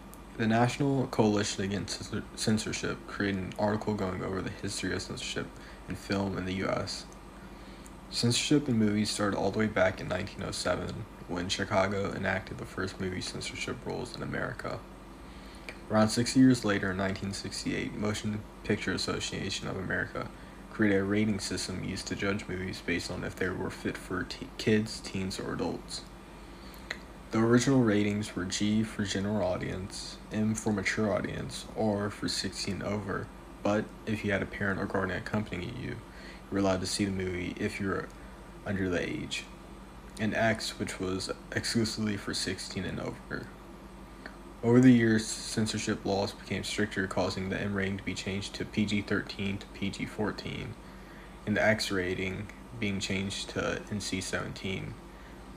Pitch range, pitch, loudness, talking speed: 95-110 Hz, 100 Hz, -31 LUFS, 160 wpm